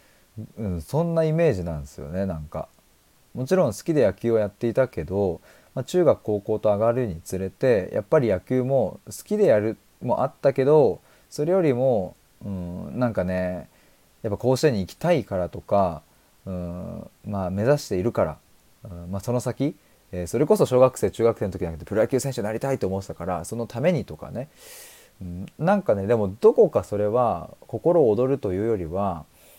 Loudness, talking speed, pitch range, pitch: -24 LUFS, 370 characters per minute, 90-130 Hz, 105 Hz